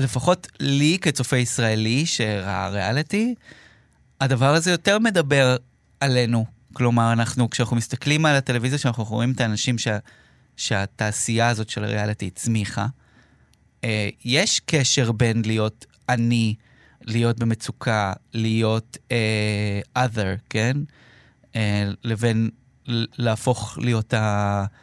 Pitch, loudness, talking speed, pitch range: 115 Hz, -22 LUFS, 105 wpm, 110-130 Hz